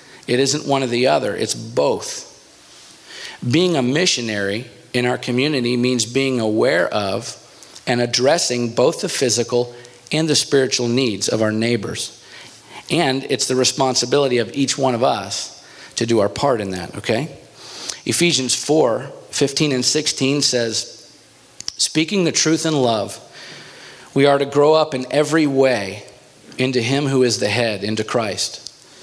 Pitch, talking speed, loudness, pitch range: 130 Hz, 150 wpm, -18 LUFS, 120-140 Hz